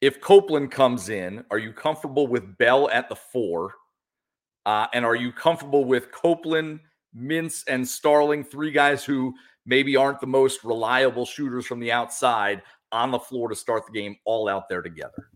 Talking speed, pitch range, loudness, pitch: 175 wpm, 120-150 Hz, -23 LUFS, 130 Hz